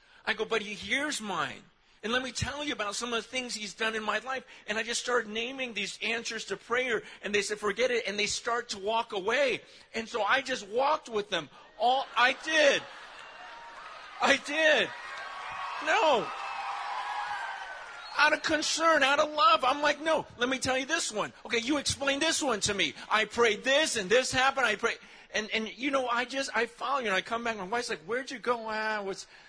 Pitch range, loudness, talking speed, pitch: 215-275 Hz, -29 LUFS, 215 wpm, 240 Hz